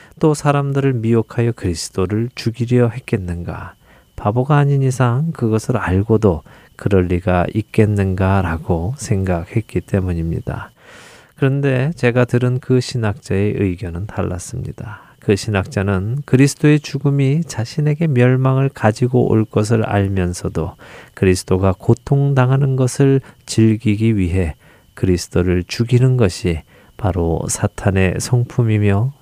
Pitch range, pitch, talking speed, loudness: 95-130 Hz, 110 Hz, 285 characters per minute, -17 LUFS